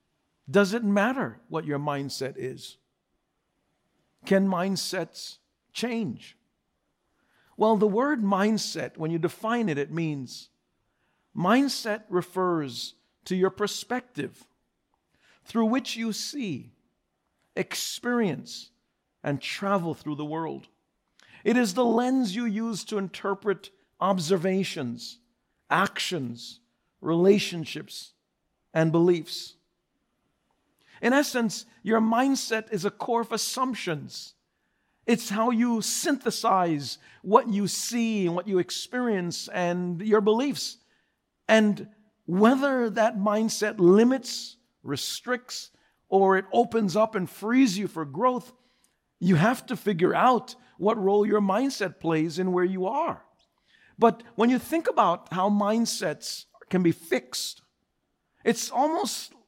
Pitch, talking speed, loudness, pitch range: 205 Hz, 115 wpm, -26 LUFS, 175-230 Hz